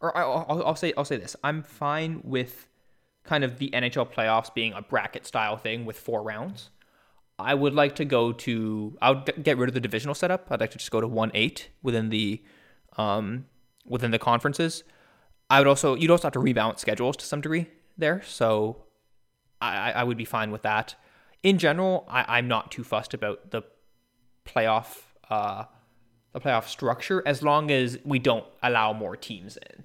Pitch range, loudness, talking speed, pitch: 110-145 Hz, -26 LUFS, 190 wpm, 125 Hz